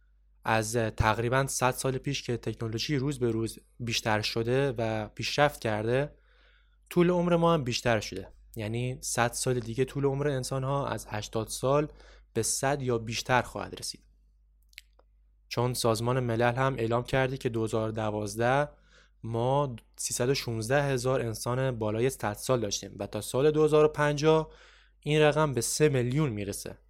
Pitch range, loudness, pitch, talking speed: 110-140 Hz, -29 LUFS, 120 Hz, 145 wpm